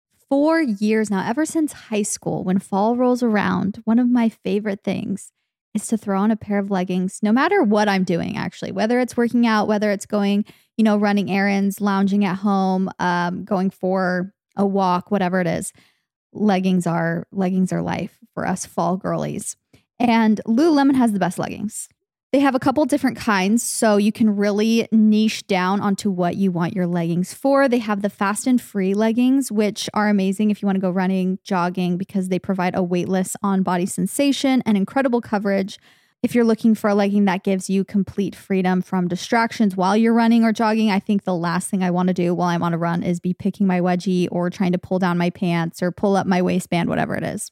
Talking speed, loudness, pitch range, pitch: 210 wpm, -20 LUFS, 185-220 Hz, 200 Hz